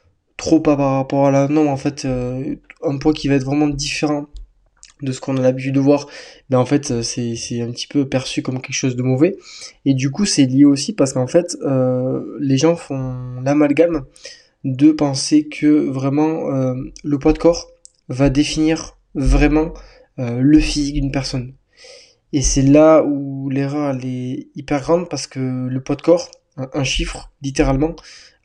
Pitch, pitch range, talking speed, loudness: 140 Hz, 135-155 Hz, 190 wpm, -18 LUFS